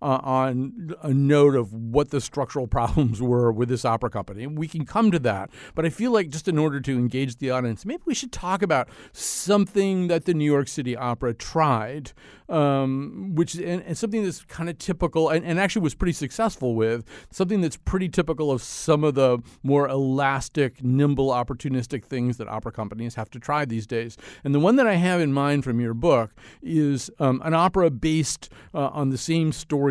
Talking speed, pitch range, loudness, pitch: 205 wpm, 125-165 Hz, -24 LUFS, 140 Hz